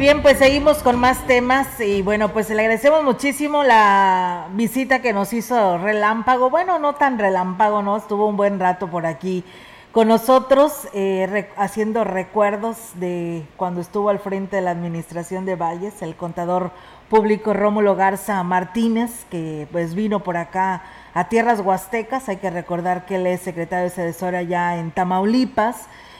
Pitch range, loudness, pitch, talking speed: 180-230 Hz, -19 LUFS, 200 Hz, 165 wpm